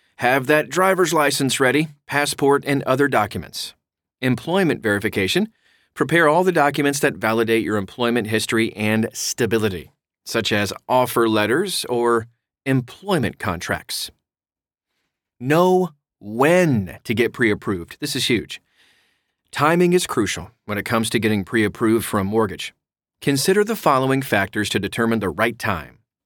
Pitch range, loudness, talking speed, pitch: 110-145 Hz, -20 LUFS, 135 wpm, 120 Hz